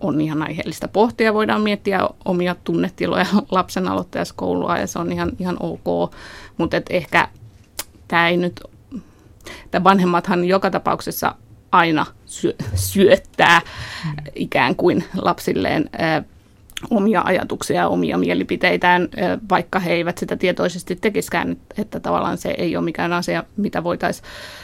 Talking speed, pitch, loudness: 125 wpm, 170 Hz, -19 LUFS